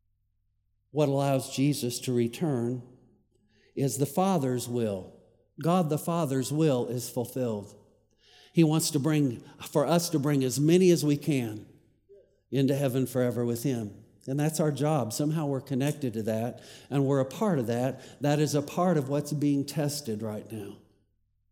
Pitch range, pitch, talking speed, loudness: 115-150 Hz, 130 Hz, 160 wpm, -28 LUFS